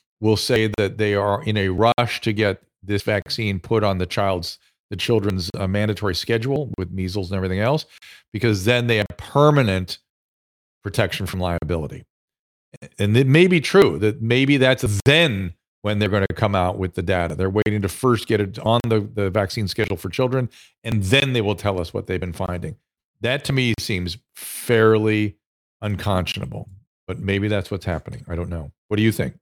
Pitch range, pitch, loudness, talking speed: 95-115 Hz, 105 Hz, -21 LUFS, 190 wpm